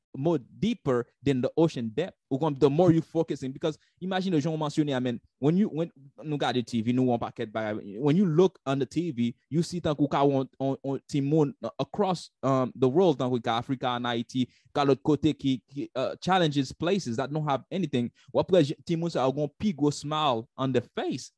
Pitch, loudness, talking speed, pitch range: 140 Hz, -28 LUFS, 180 wpm, 125-160 Hz